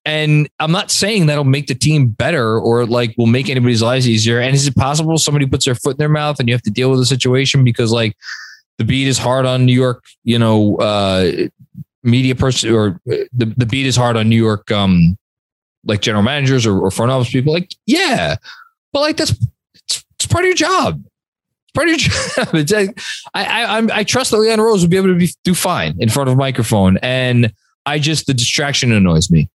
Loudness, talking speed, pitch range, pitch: -14 LUFS, 225 wpm, 115-155 Hz, 130 Hz